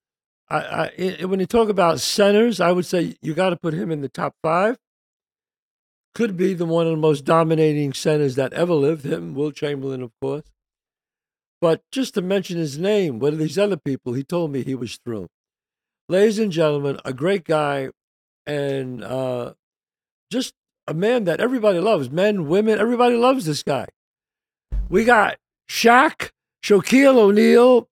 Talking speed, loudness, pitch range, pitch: 170 wpm, -20 LUFS, 150-215 Hz, 170 Hz